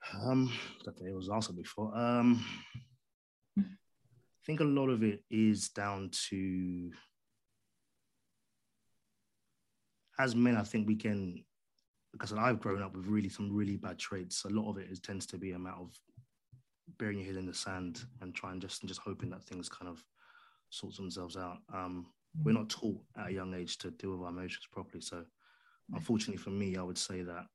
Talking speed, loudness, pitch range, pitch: 185 wpm, -37 LUFS, 95-120 Hz, 100 Hz